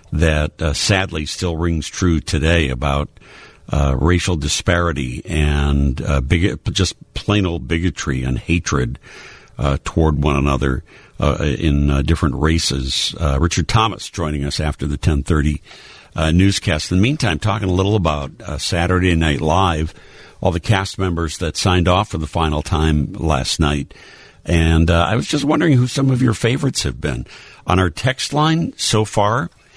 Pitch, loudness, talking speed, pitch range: 85 Hz, -18 LUFS, 165 wpm, 75-95 Hz